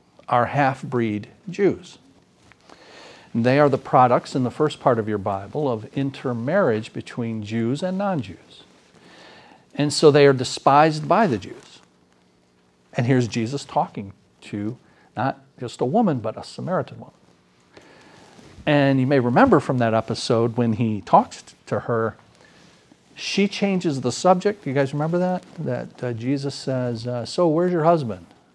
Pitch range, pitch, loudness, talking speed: 110-150 Hz, 125 Hz, -21 LUFS, 150 wpm